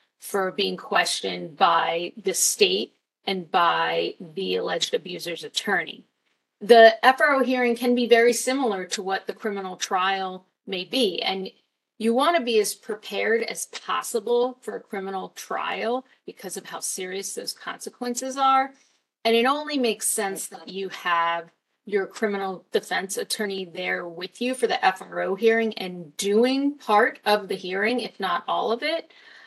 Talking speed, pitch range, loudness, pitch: 155 wpm, 190-250 Hz, -24 LUFS, 215 Hz